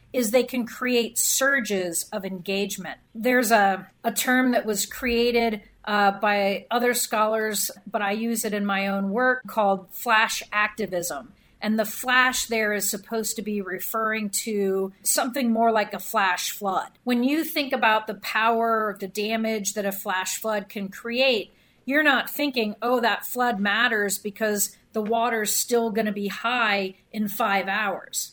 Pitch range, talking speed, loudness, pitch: 200-235 Hz, 165 wpm, -24 LUFS, 220 Hz